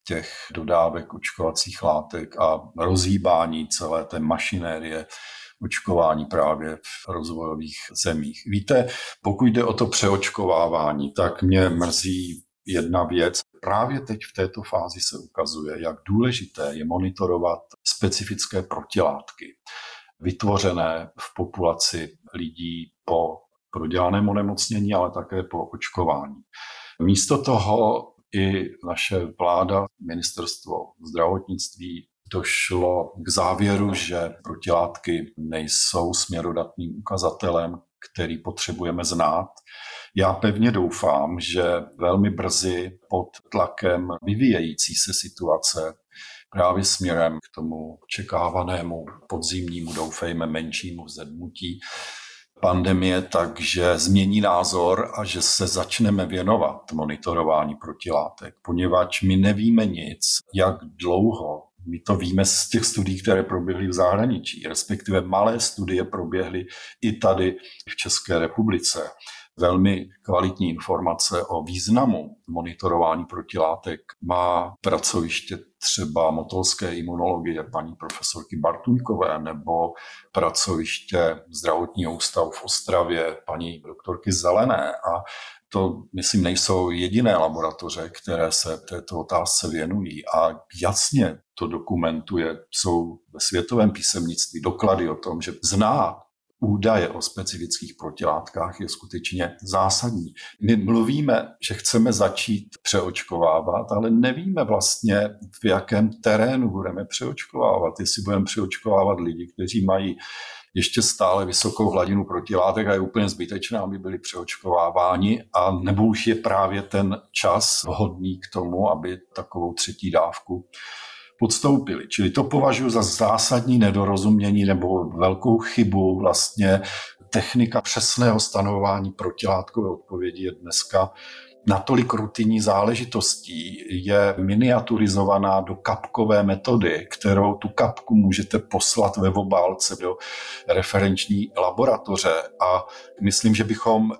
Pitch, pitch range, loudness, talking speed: 95 Hz, 85-105 Hz, -23 LUFS, 110 wpm